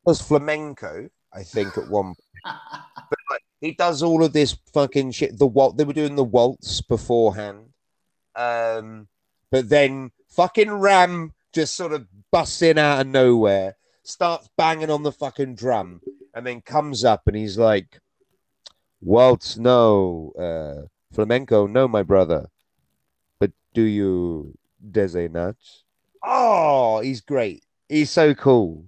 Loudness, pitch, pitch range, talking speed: -20 LUFS, 125 Hz, 105-150 Hz, 140 wpm